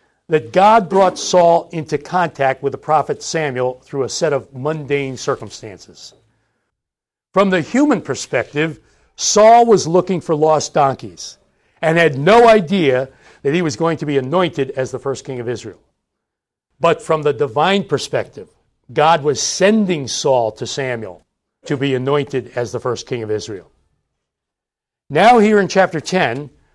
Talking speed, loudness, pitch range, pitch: 155 wpm, -16 LUFS, 130-180 Hz, 150 Hz